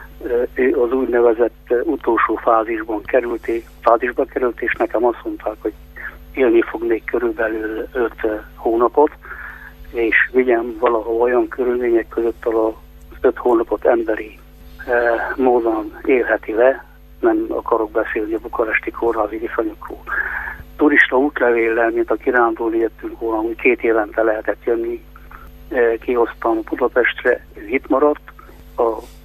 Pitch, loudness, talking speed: 120 Hz, -18 LUFS, 115 wpm